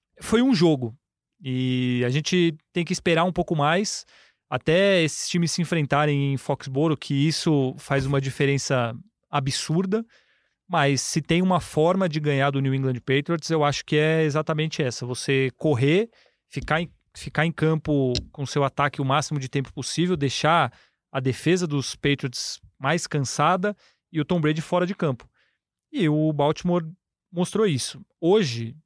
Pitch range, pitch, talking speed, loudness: 140-170 Hz, 150 Hz, 160 wpm, -24 LUFS